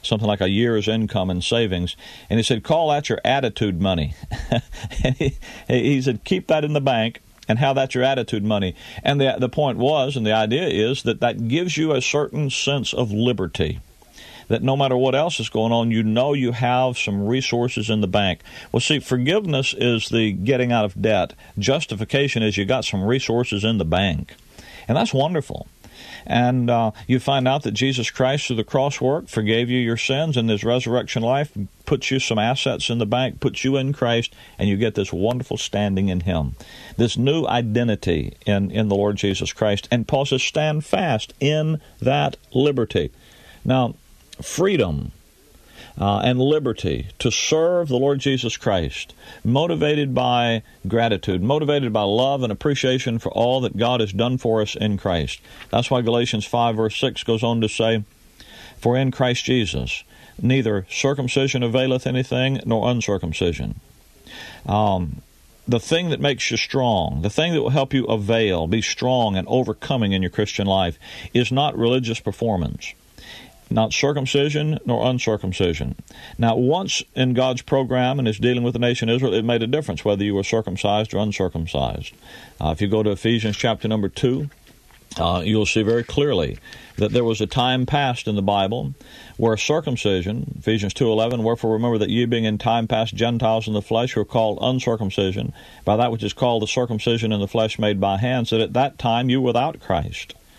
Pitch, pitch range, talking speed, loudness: 115 Hz, 105-130 Hz, 185 wpm, -21 LUFS